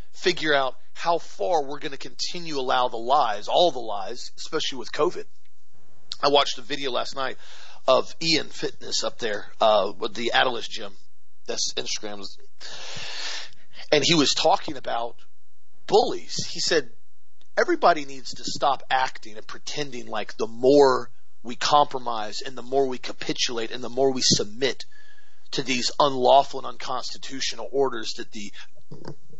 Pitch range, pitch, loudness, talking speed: 125-155 Hz, 135 Hz, -24 LUFS, 150 wpm